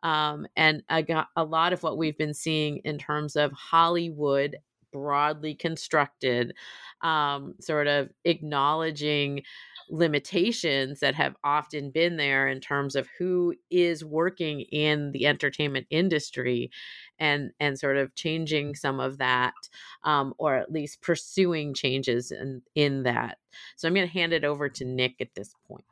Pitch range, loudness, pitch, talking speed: 140-160 Hz, -27 LUFS, 150 Hz, 150 wpm